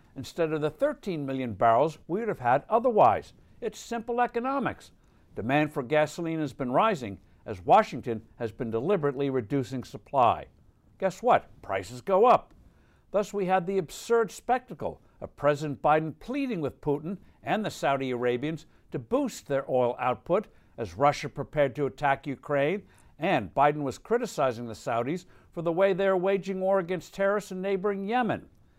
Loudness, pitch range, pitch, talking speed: -28 LUFS, 135-195 Hz, 150 Hz, 160 wpm